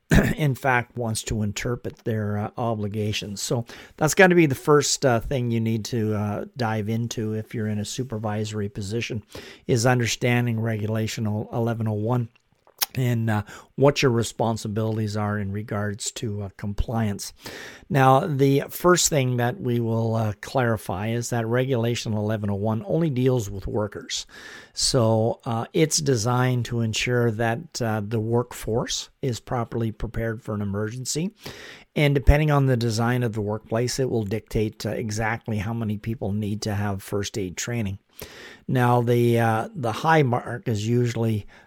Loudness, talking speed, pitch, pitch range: -24 LUFS, 155 wpm, 115 Hz, 110-125 Hz